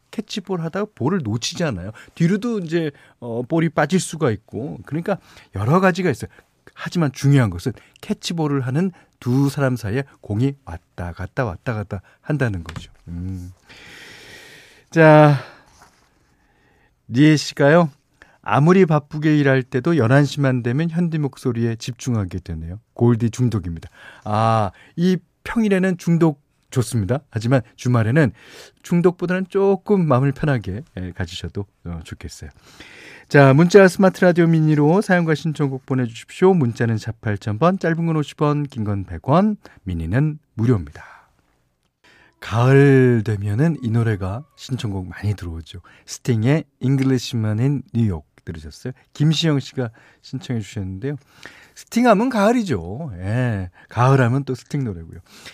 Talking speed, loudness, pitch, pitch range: 285 characters per minute, -19 LUFS, 130 Hz, 110-160 Hz